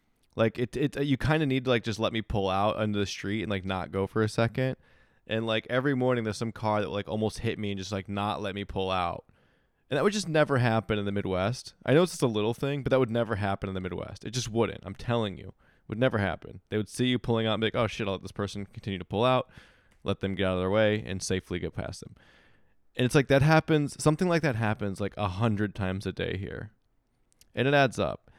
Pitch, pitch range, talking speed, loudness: 110 Hz, 100-125 Hz, 275 wpm, -29 LUFS